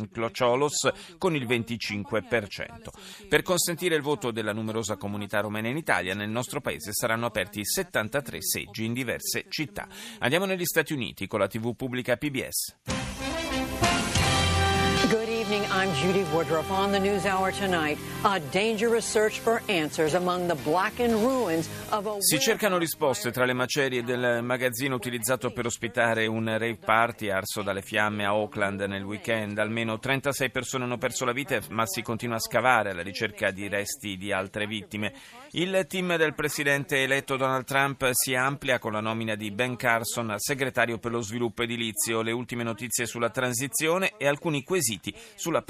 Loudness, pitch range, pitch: -27 LUFS, 110-155 Hz, 125 Hz